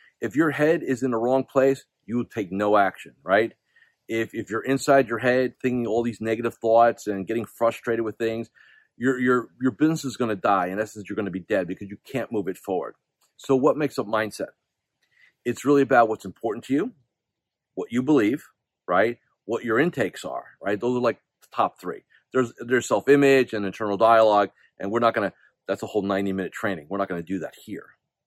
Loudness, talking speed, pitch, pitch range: -24 LUFS, 210 wpm, 115 Hz, 105-130 Hz